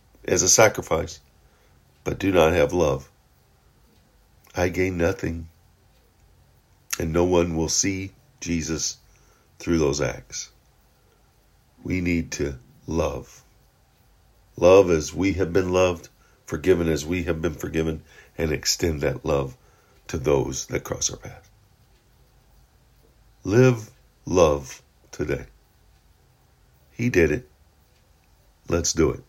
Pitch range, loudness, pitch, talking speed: 80-95 Hz, -23 LUFS, 85 Hz, 115 wpm